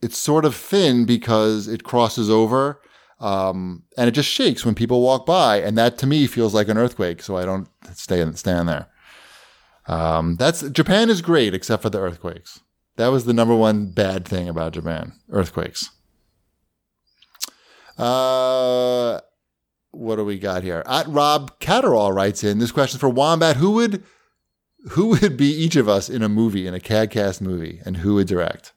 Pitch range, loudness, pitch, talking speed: 95-130 Hz, -19 LUFS, 115 Hz, 175 wpm